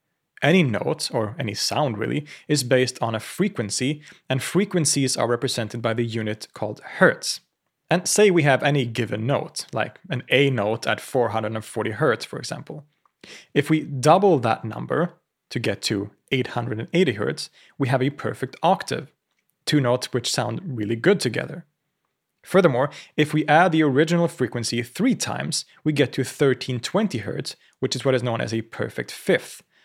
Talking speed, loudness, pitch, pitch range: 165 wpm, -23 LUFS, 130 Hz, 120-155 Hz